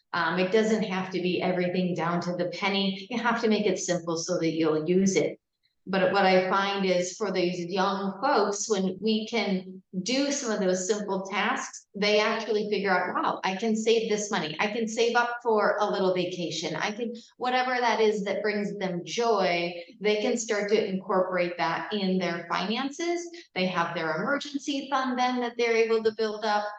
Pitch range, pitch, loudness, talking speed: 185-225 Hz, 205 Hz, -27 LUFS, 195 wpm